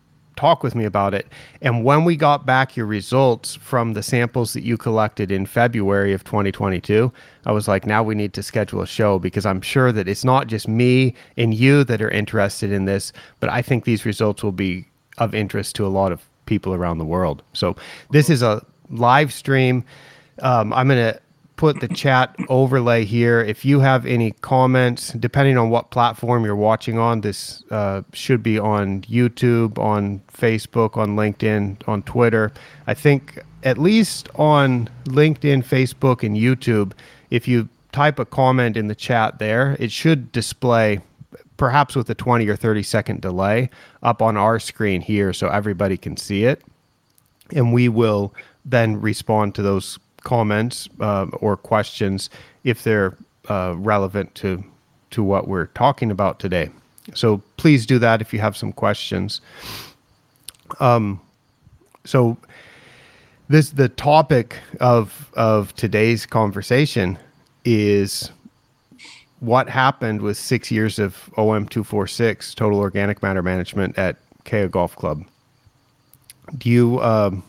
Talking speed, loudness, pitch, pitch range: 155 wpm, -19 LUFS, 115 Hz, 105-130 Hz